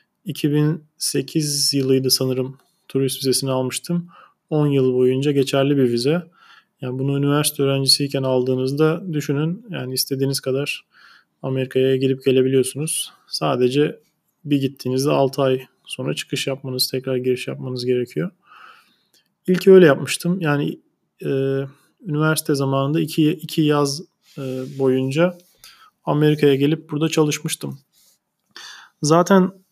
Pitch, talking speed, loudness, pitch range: 145 Hz, 105 wpm, -20 LUFS, 130-160 Hz